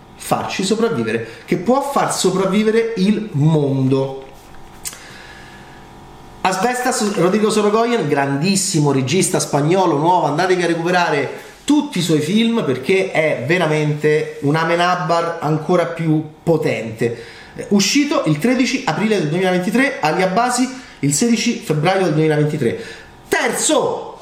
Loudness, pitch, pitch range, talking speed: -17 LUFS, 180 Hz, 150-220 Hz, 105 wpm